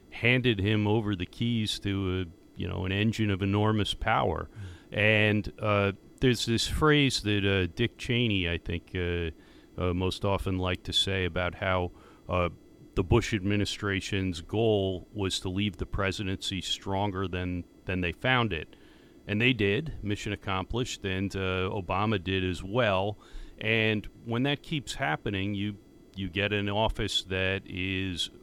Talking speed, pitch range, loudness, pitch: 155 wpm, 95-110 Hz, -29 LUFS, 100 Hz